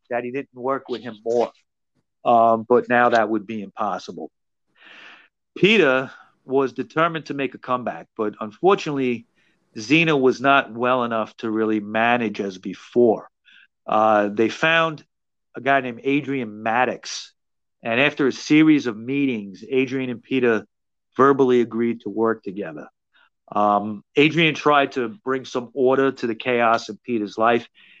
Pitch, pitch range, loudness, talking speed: 120 Hz, 110-135 Hz, -21 LUFS, 145 wpm